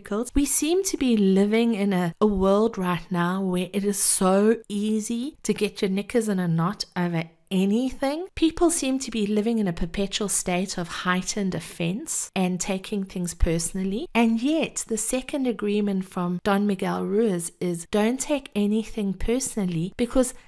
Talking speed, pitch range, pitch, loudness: 165 wpm, 185-230 Hz, 205 Hz, -24 LUFS